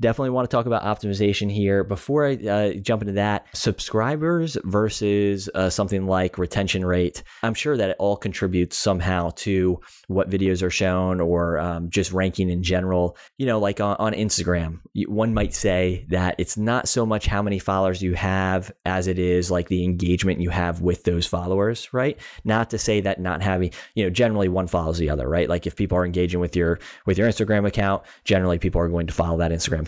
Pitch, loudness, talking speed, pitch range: 95 Hz, -23 LUFS, 205 wpm, 90-105 Hz